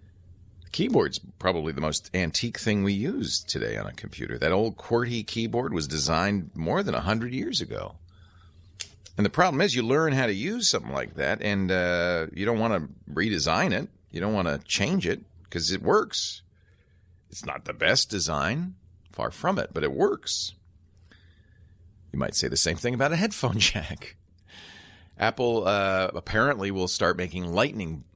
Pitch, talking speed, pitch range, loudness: 95 Hz, 175 wpm, 90-105 Hz, -26 LUFS